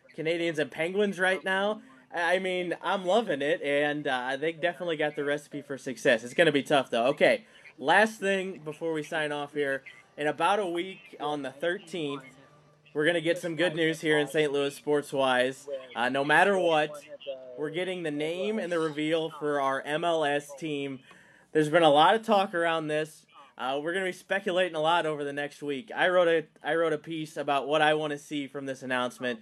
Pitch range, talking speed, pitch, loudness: 145-175 Hz, 210 wpm, 155 Hz, -28 LUFS